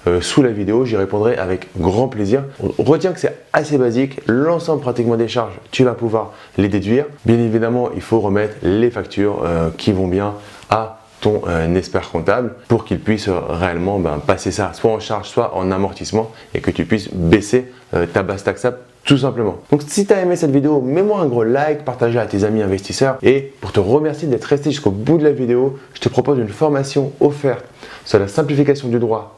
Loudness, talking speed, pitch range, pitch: -17 LUFS, 195 wpm, 100-135 Hz, 115 Hz